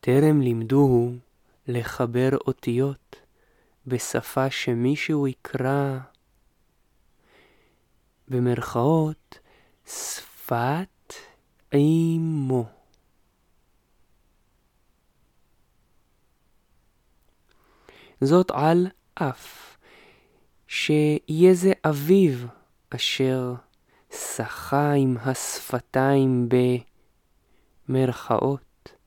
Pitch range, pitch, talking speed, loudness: 120-150 Hz, 130 Hz, 45 wpm, -23 LUFS